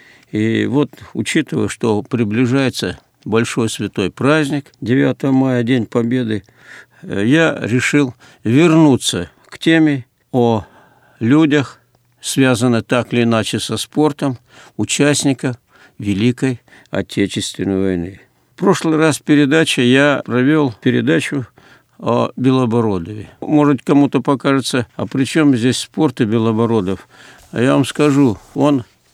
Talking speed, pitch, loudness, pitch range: 110 wpm, 125 Hz, -16 LUFS, 115-145 Hz